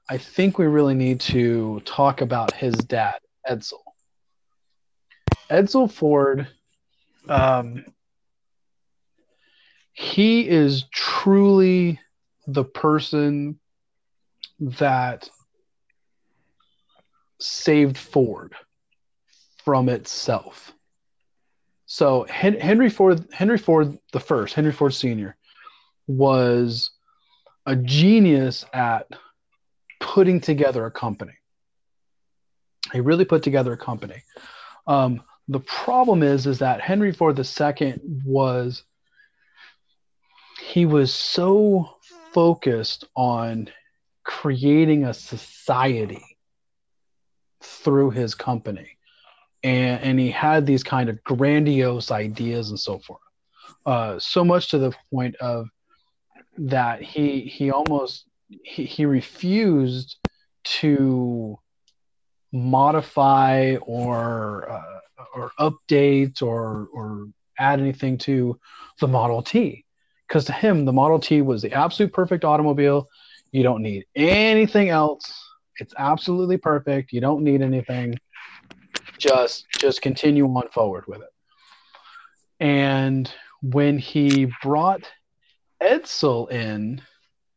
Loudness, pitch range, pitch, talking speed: -21 LUFS, 125-160 Hz, 140 Hz, 100 wpm